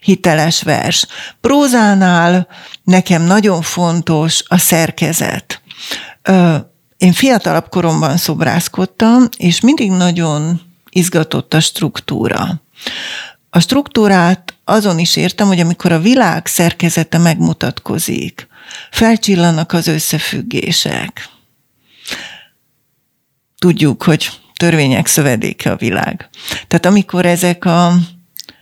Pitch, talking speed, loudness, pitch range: 175 Hz, 90 wpm, -12 LUFS, 165-190 Hz